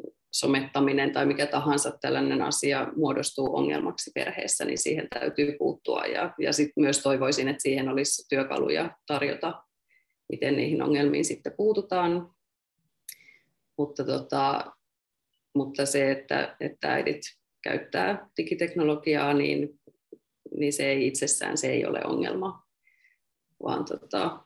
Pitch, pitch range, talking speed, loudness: 145 Hz, 140-155 Hz, 120 wpm, -27 LUFS